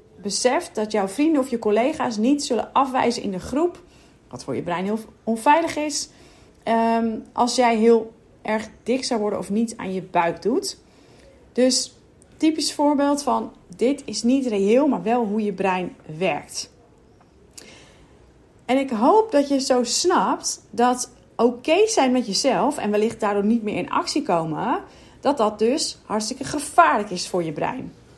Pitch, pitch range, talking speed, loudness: 235 Hz, 215-280 Hz, 165 wpm, -22 LUFS